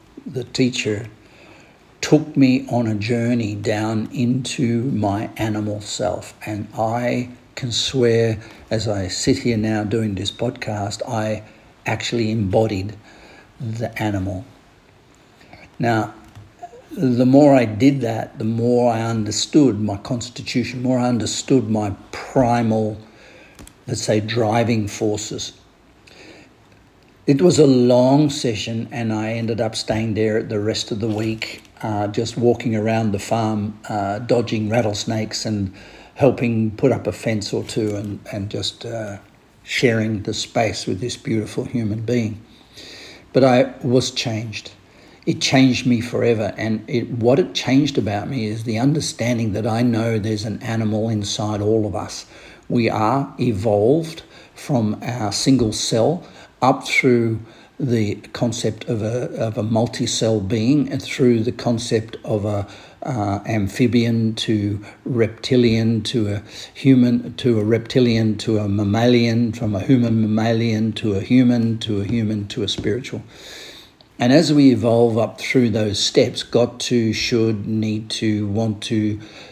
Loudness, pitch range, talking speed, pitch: -20 LUFS, 105-120 Hz, 140 wpm, 115 Hz